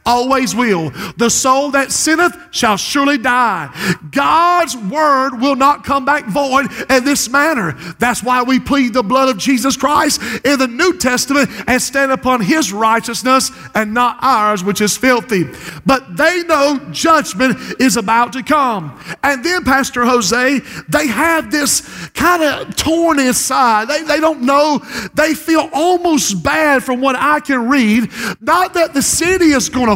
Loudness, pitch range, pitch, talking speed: -13 LUFS, 235-290 Hz, 265 Hz, 165 wpm